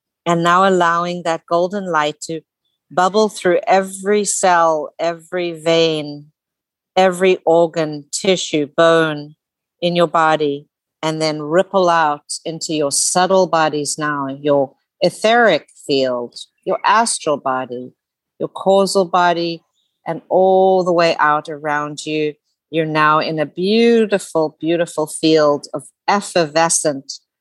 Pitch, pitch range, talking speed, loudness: 165 Hz, 150-180 Hz, 120 wpm, -16 LUFS